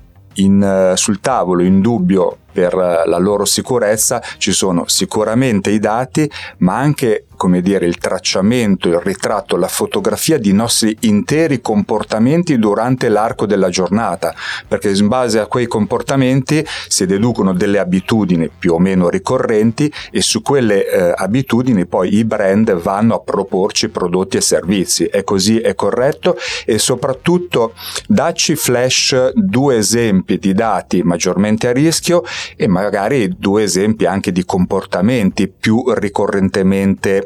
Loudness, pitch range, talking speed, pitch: -14 LUFS, 95-135 Hz, 135 wpm, 110 Hz